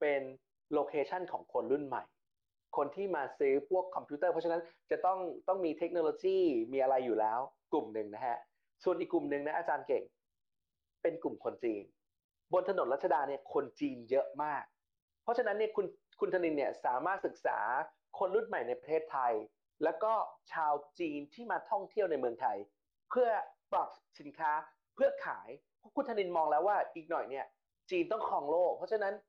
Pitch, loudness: 175 Hz, -36 LUFS